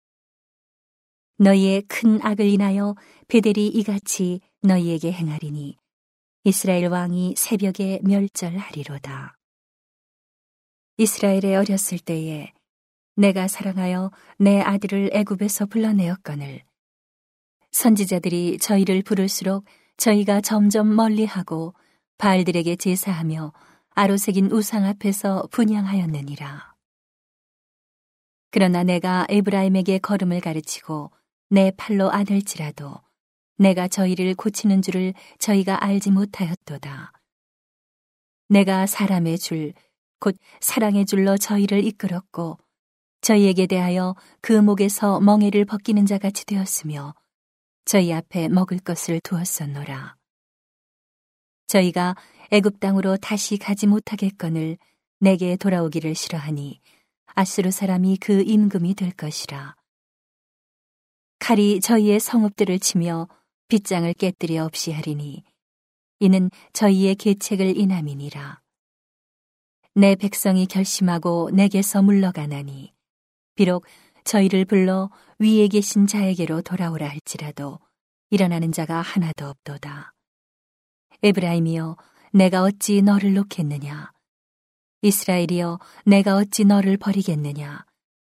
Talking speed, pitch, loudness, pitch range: 255 characters per minute, 190 Hz, -20 LUFS, 170-200 Hz